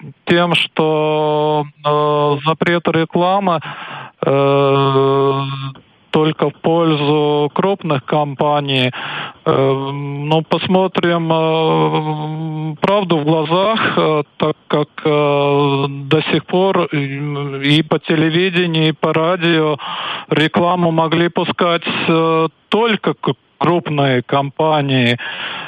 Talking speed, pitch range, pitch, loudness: 90 wpm, 145-170 Hz, 155 Hz, -15 LUFS